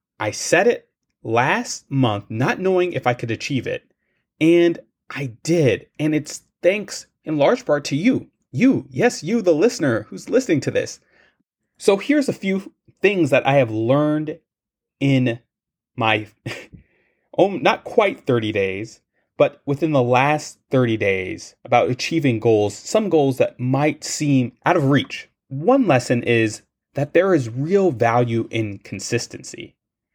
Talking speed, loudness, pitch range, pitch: 150 wpm, -20 LUFS, 120-170 Hz, 140 Hz